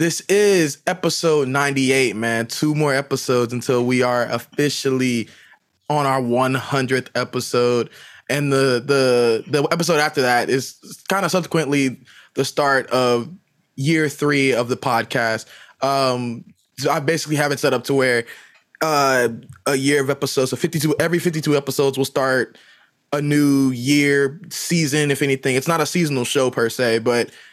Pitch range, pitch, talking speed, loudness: 125-150 Hz, 135 Hz, 155 wpm, -19 LUFS